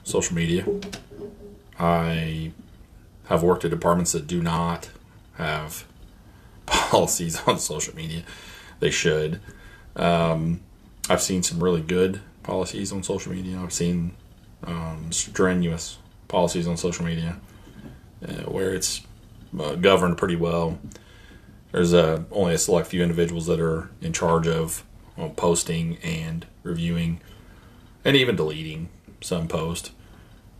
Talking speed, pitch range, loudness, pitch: 125 wpm, 85-100 Hz, -24 LUFS, 85 Hz